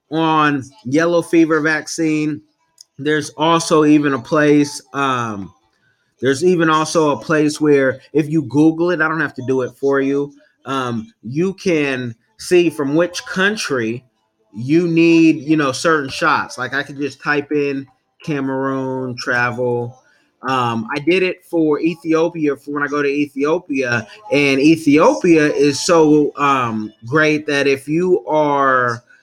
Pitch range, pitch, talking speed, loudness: 135-160 Hz, 145 Hz, 145 wpm, -16 LUFS